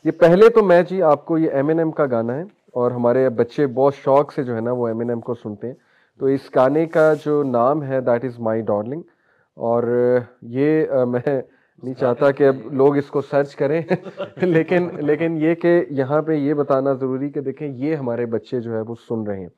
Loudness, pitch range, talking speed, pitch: -19 LUFS, 120-155 Hz, 225 wpm, 140 Hz